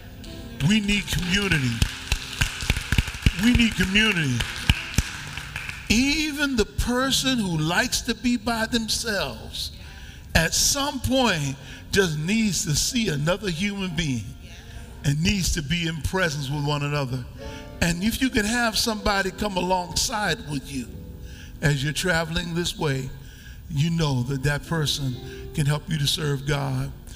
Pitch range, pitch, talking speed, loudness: 140-215 Hz, 170 Hz, 135 wpm, -24 LUFS